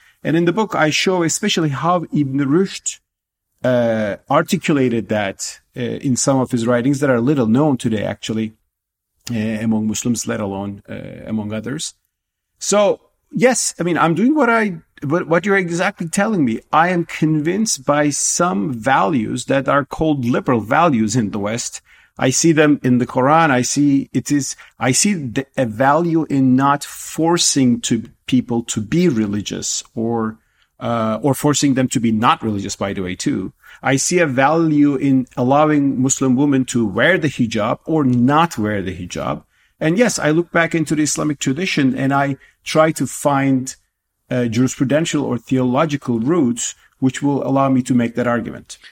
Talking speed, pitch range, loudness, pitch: 170 wpm, 120-155 Hz, -17 LUFS, 135 Hz